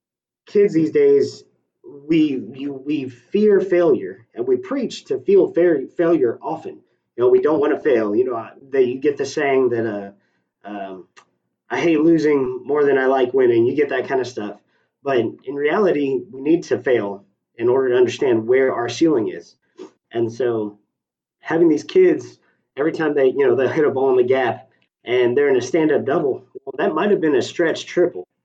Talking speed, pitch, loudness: 200 wpm, 370 Hz, -18 LUFS